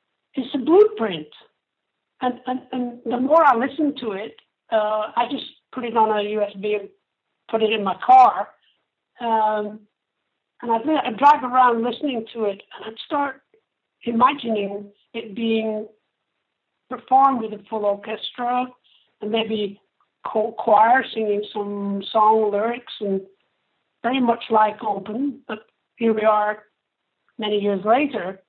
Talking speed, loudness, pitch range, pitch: 135 wpm, -21 LUFS, 210-255 Hz, 225 Hz